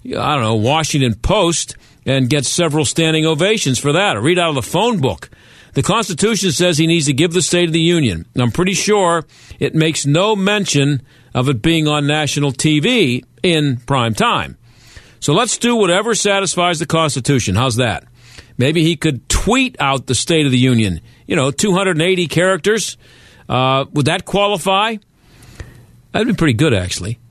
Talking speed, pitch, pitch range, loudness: 175 wpm, 150 Hz, 125-175 Hz, -15 LUFS